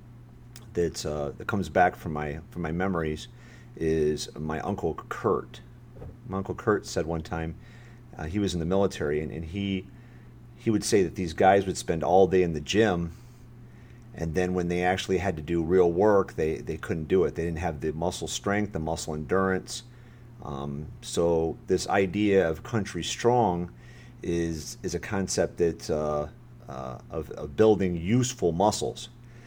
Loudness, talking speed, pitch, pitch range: -27 LUFS, 175 wpm, 90 Hz, 80-110 Hz